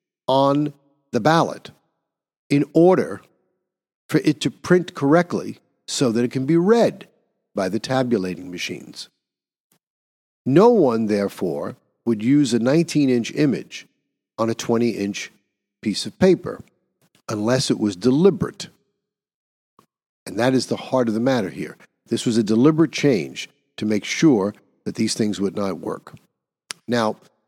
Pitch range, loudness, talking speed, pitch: 110-145 Hz, -20 LUFS, 135 wpm, 120 Hz